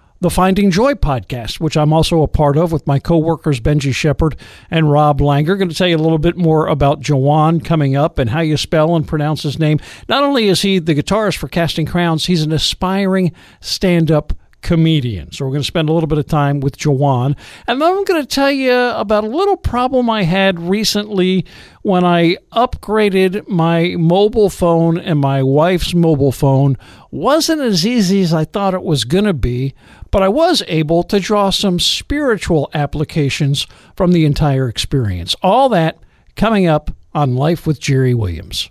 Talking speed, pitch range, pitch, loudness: 195 wpm, 145-195 Hz, 165 Hz, -14 LUFS